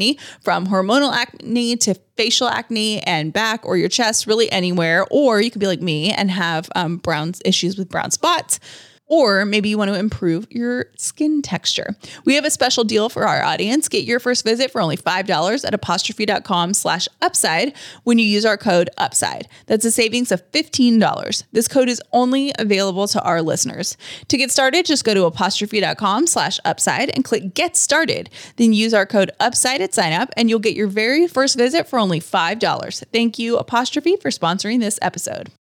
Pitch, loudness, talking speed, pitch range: 220 Hz, -18 LUFS, 180 wpm, 195-250 Hz